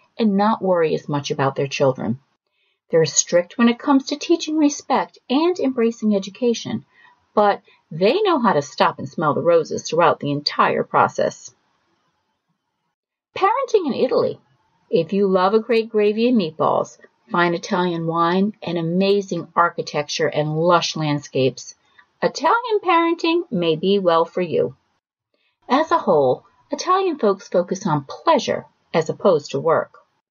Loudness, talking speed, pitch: -19 LUFS, 145 wpm, 200 Hz